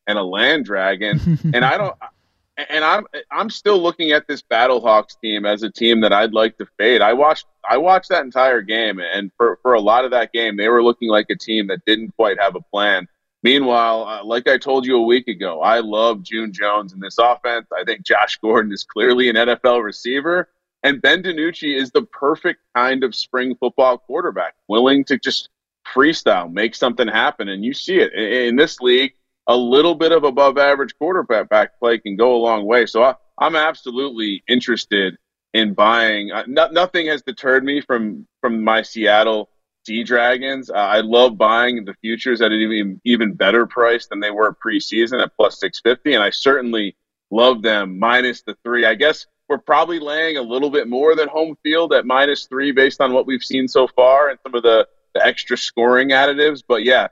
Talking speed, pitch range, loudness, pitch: 205 wpm, 110-140 Hz, -16 LUFS, 120 Hz